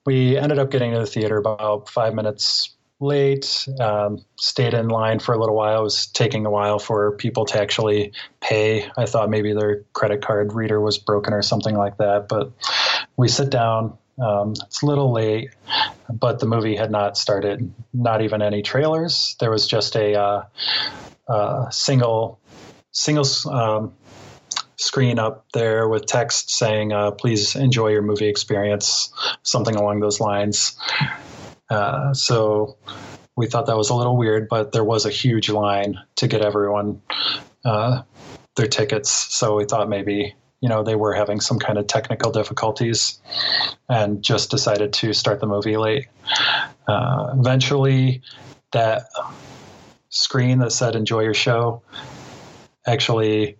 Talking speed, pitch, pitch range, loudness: 155 wpm, 110 Hz, 105-125 Hz, -20 LUFS